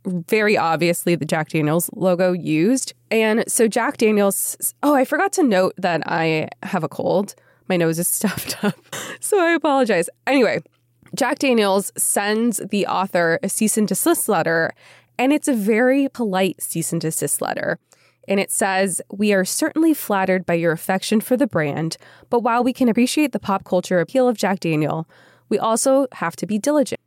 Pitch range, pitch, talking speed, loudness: 170-245 Hz, 195 Hz, 175 wpm, -19 LUFS